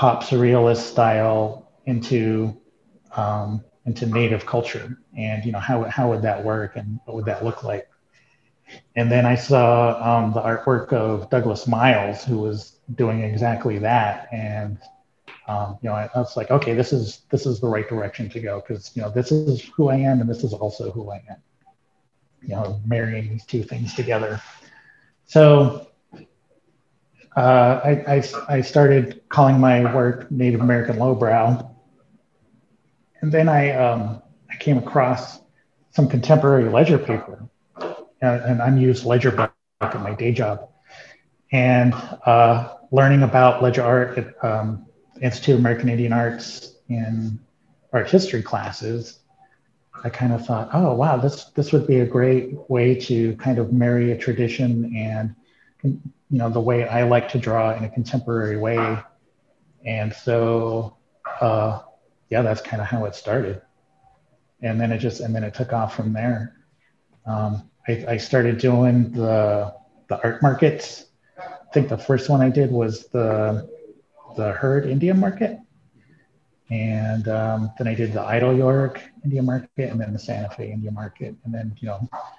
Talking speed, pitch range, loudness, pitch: 160 wpm, 110-130 Hz, -20 LUFS, 120 Hz